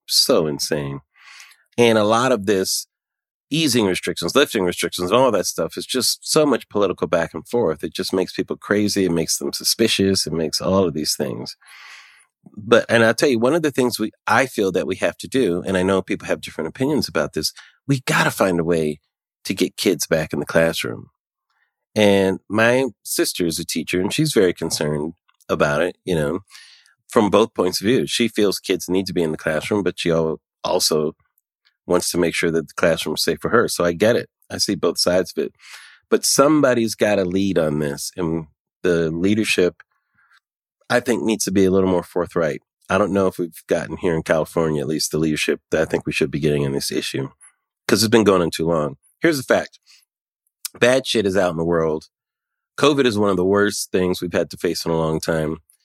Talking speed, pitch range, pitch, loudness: 215 wpm, 80-105 Hz, 90 Hz, -19 LUFS